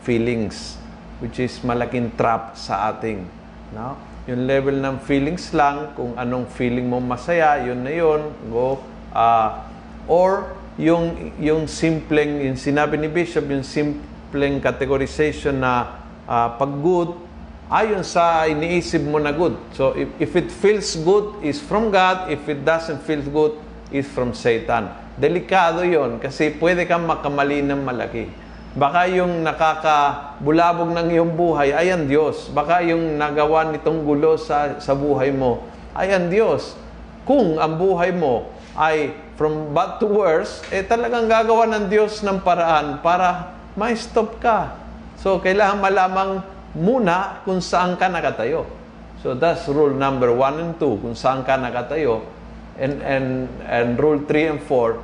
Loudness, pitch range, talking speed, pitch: -20 LUFS, 135-180 Hz, 145 wpm, 155 Hz